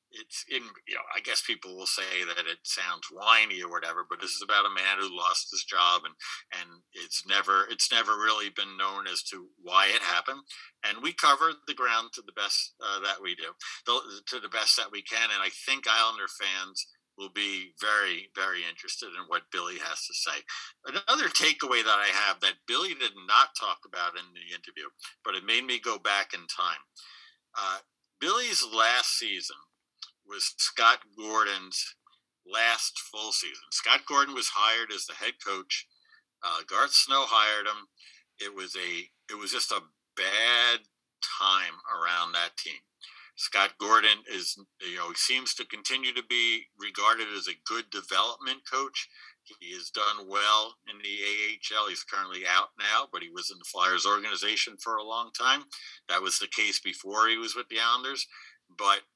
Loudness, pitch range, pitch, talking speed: -27 LUFS, 100-125 Hz, 110 Hz, 185 wpm